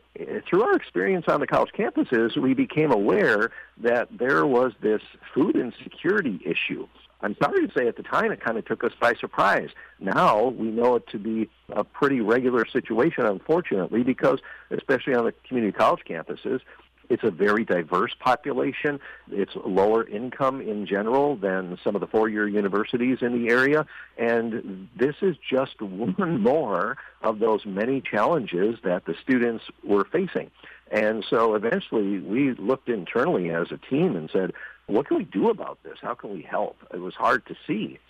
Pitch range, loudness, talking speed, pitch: 105-135 Hz, -24 LUFS, 175 wpm, 120 Hz